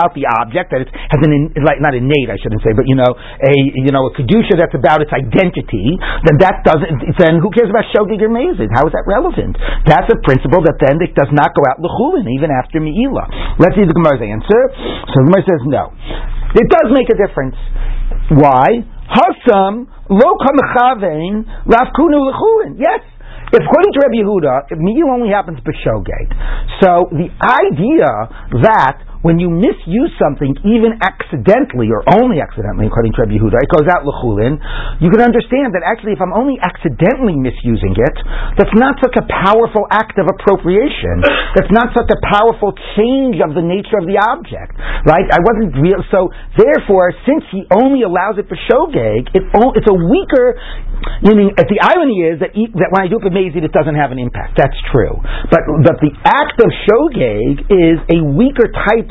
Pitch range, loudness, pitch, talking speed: 145-220 Hz, -12 LUFS, 185 Hz, 180 wpm